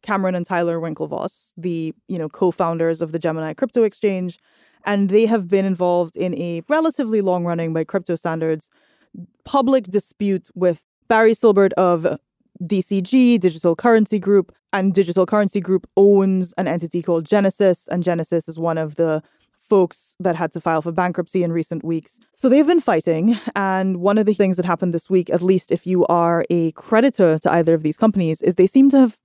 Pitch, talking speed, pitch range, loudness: 185 Hz, 185 wpm, 170-205 Hz, -18 LUFS